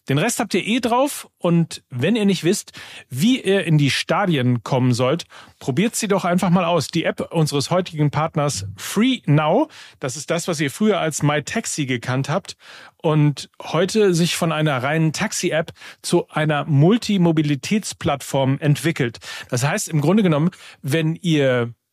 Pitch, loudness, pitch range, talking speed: 160 Hz, -20 LUFS, 145-190 Hz, 165 wpm